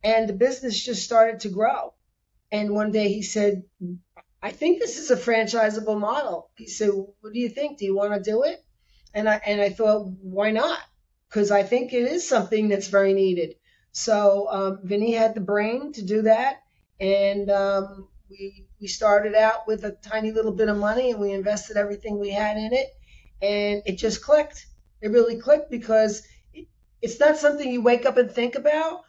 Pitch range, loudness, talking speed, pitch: 205-240 Hz, -23 LUFS, 195 wpm, 215 Hz